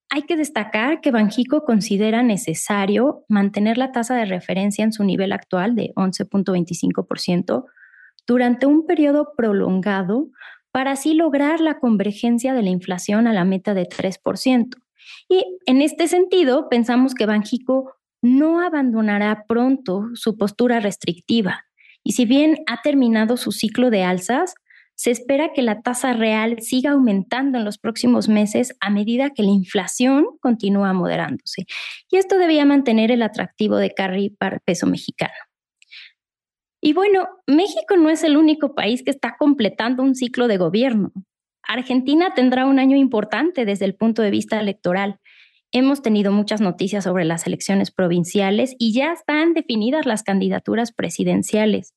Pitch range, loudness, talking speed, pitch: 205-275 Hz, -19 LUFS, 150 wpm, 235 Hz